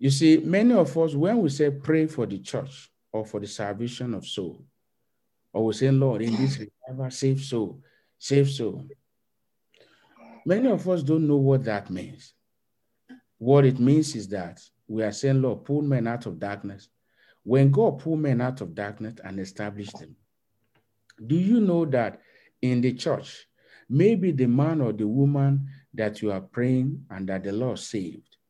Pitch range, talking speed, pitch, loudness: 110-140 Hz, 175 wpm, 130 Hz, -25 LUFS